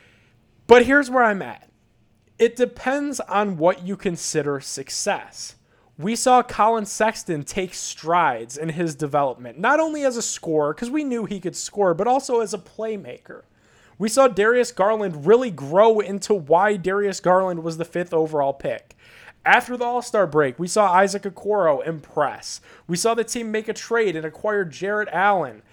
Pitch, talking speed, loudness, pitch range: 200 Hz, 170 wpm, -21 LUFS, 165-230 Hz